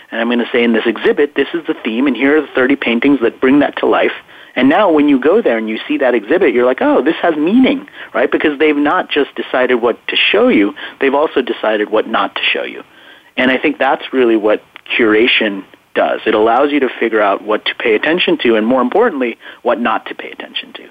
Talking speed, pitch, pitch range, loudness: 245 wpm, 130 Hz, 115-155 Hz, -13 LUFS